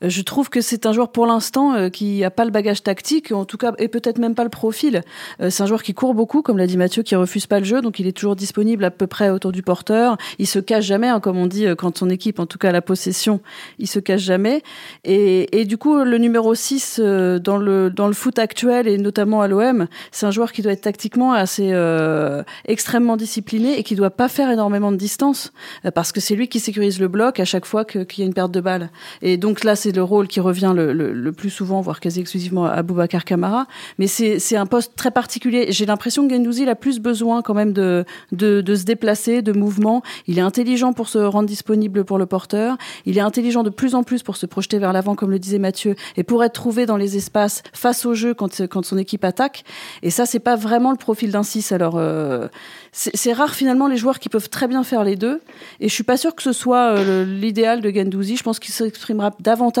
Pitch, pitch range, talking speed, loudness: 210 Hz, 195-235 Hz, 250 wpm, -18 LUFS